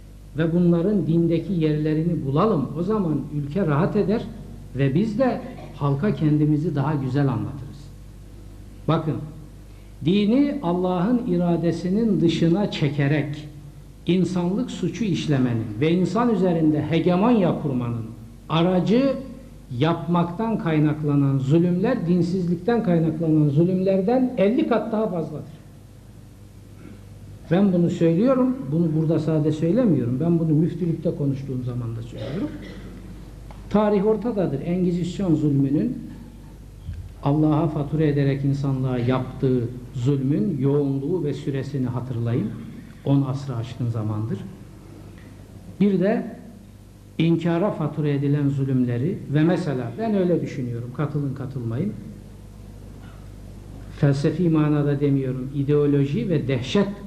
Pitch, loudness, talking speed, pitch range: 150 Hz, -22 LUFS, 100 wpm, 125-175 Hz